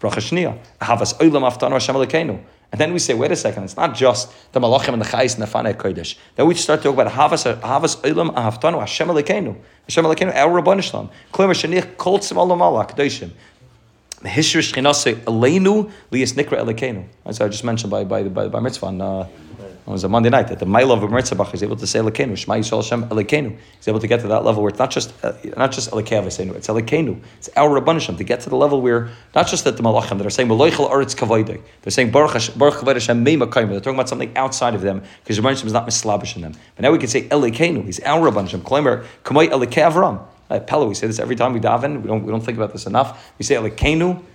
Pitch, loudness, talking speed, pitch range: 120 Hz, -18 LUFS, 210 wpm, 110-140 Hz